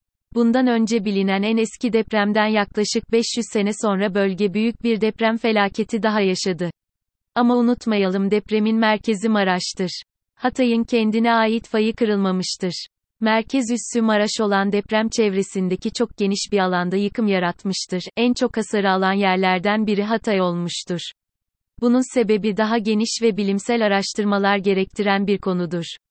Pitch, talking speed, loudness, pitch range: 210 Hz, 130 wpm, -20 LUFS, 195-225 Hz